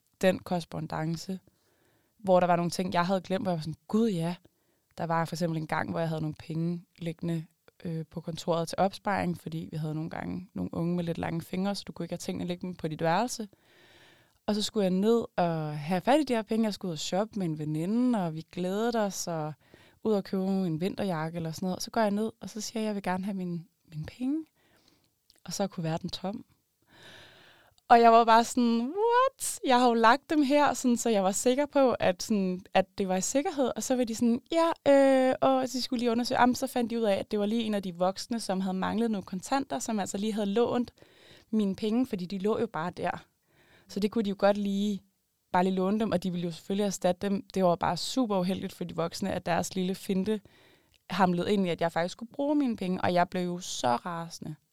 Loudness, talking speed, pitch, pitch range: -29 LUFS, 250 wpm, 190 Hz, 175-230 Hz